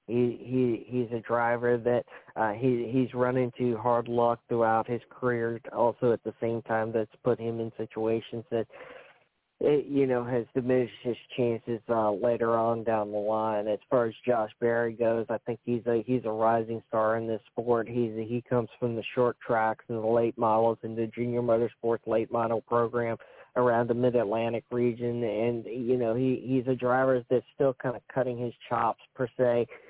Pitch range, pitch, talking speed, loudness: 115-120 Hz, 120 Hz, 195 wpm, -29 LUFS